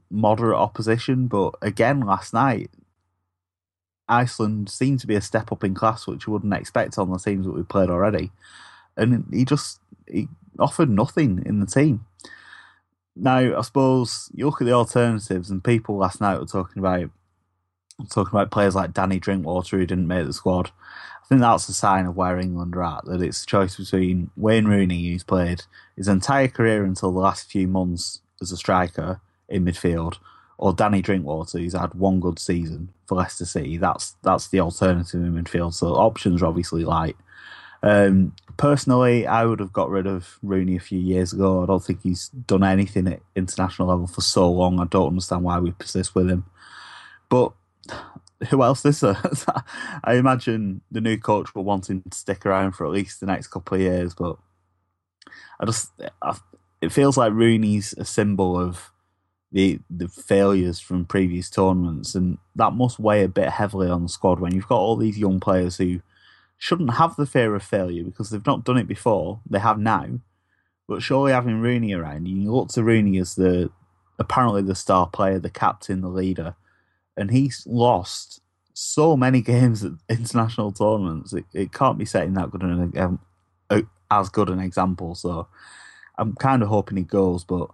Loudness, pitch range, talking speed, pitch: -22 LUFS, 90-110 Hz, 185 wpm, 95 Hz